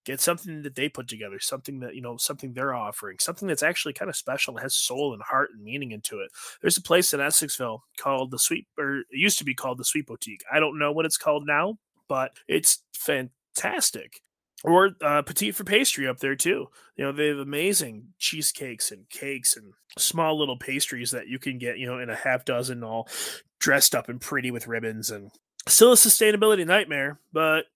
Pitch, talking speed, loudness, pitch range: 140 Hz, 210 wpm, -24 LUFS, 125-160 Hz